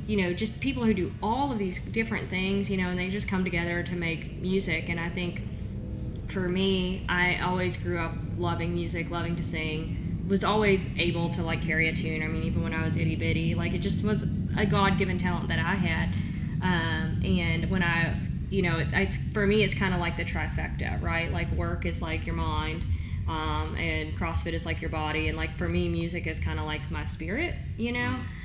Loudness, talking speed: -28 LUFS, 220 wpm